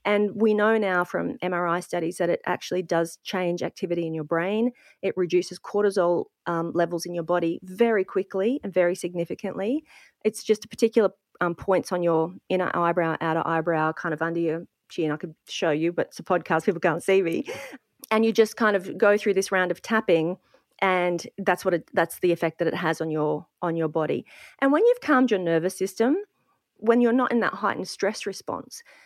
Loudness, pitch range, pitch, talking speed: -25 LUFS, 170-215 Hz, 180 Hz, 205 wpm